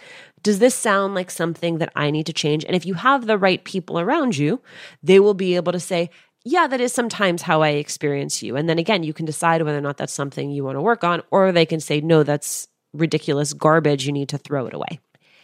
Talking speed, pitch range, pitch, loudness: 245 wpm, 150-195 Hz, 165 Hz, -20 LUFS